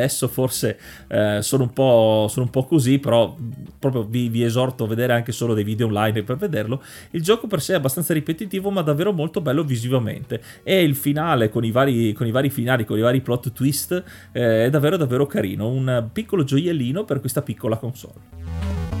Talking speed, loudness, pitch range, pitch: 200 wpm, -21 LUFS, 115-145 Hz, 125 Hz